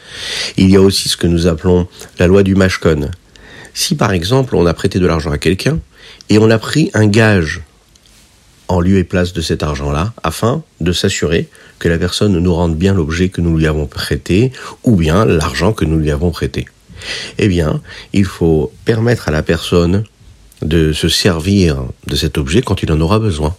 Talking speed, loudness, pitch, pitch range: 195 wpm, -14 LUFS, 90 Hz, 80-100 Hz